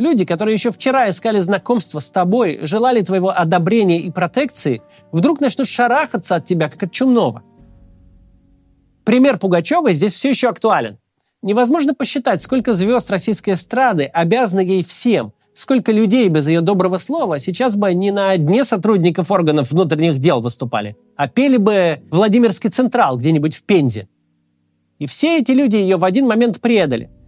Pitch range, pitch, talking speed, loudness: 160-240 Hz, 195 Hz, 150 wpm, -16 LUFS